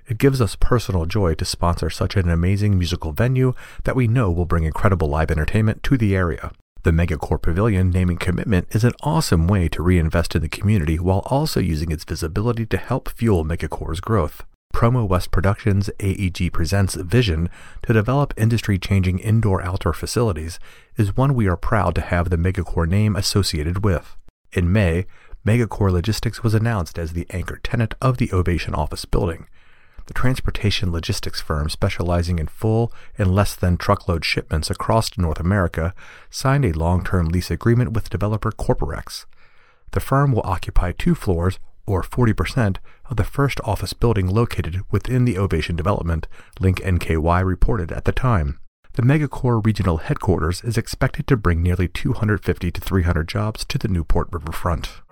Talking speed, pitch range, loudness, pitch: 165 wpm, 85-110 Hz, -21 LUFS, 95 Hz